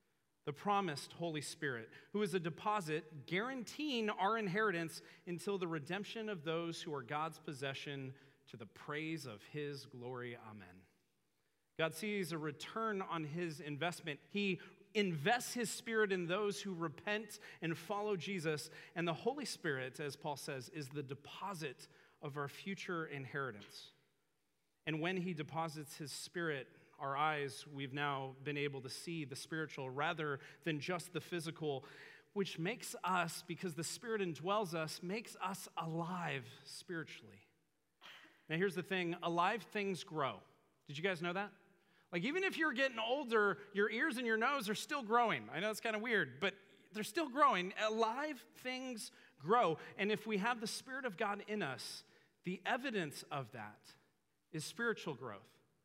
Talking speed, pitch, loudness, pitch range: 160 wpm, 170 Hz, -40 LUFS, 150-205 Hz